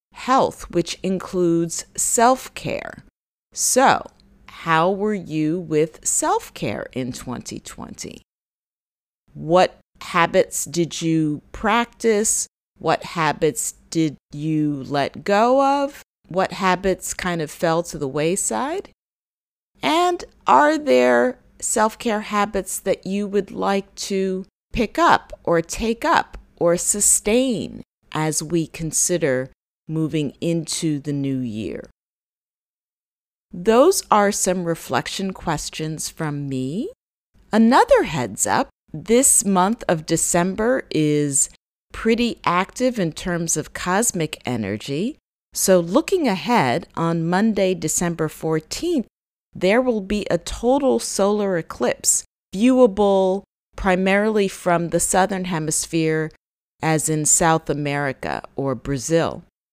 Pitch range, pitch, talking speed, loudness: 155-215 Hz, 180 Hz, 105 wpm, -20 LUFS